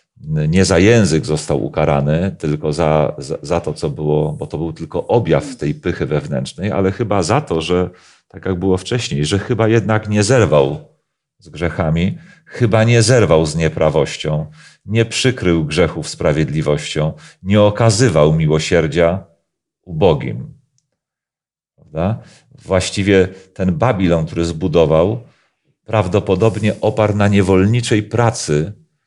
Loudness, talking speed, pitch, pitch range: -16 LUFS, 125 wpm, 95 Hz, 80-115 Hz